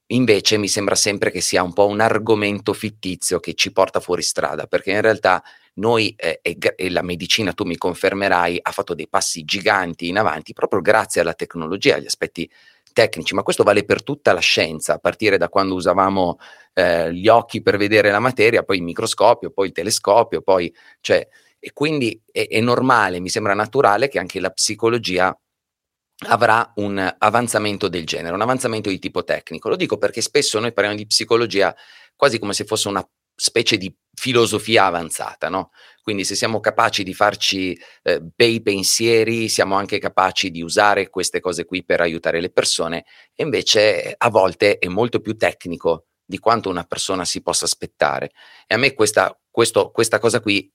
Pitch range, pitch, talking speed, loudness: 95-115 Hz, 105 Hz, 180 wpm, -18 LUFS